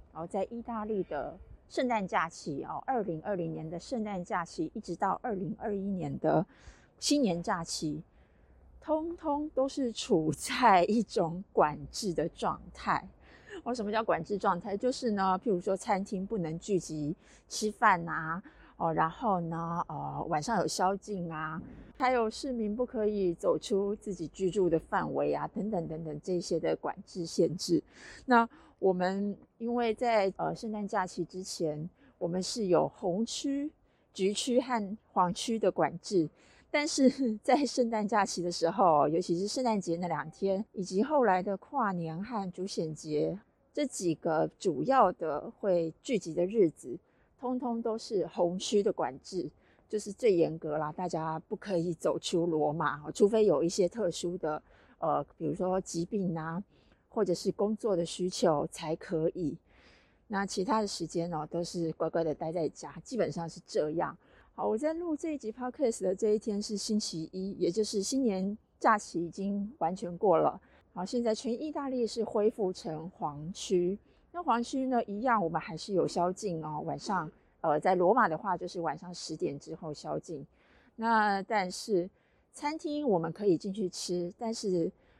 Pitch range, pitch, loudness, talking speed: 170-225 Hz, 195 Hz, -32 LUFS, 245 characters per minute